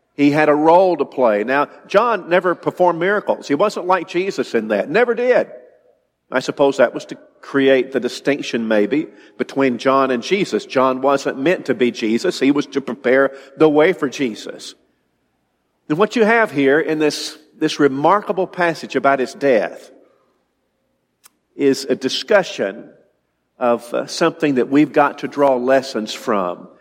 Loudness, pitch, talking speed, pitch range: -17 LUFS, 140 Hz, 160 wpm, 130-170 Hz